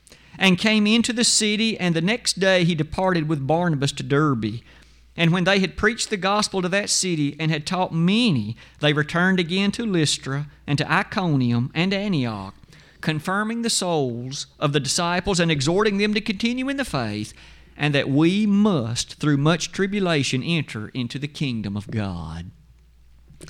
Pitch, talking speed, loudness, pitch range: 165 Hz, 170 wpm, -21 LUFS, 135-195 Hz